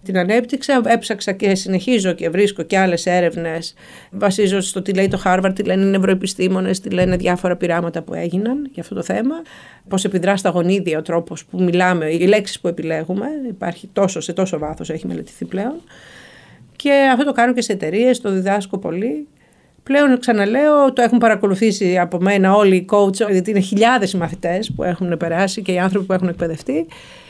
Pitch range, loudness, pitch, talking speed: 180-215 Hz, -17 LUFS, 195 Hz, 185 wpm